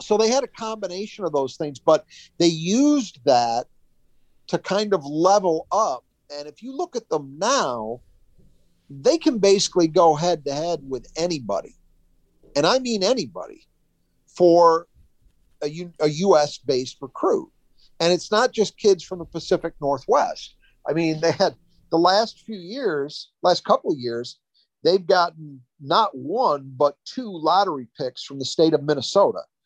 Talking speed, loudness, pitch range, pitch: 160 wpm, -22 LUFS, 145-200 Hz, 170 Hz